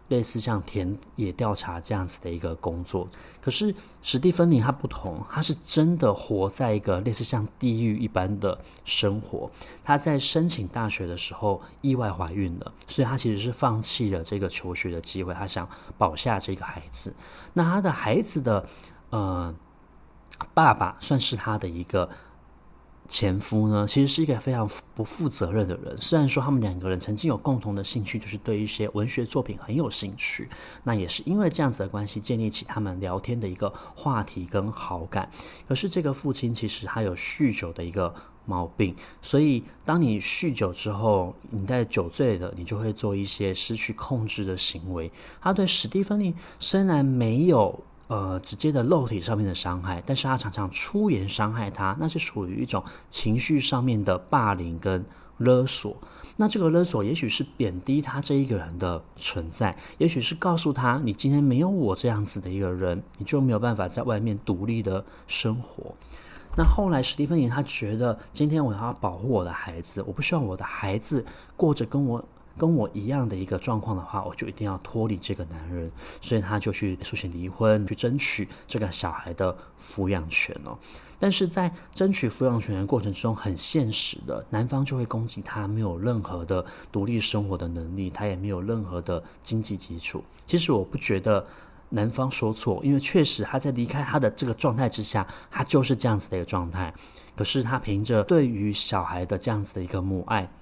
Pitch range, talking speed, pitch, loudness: 95-135 Hz, 290 characters per minute, 110 Hz, -26 LUFS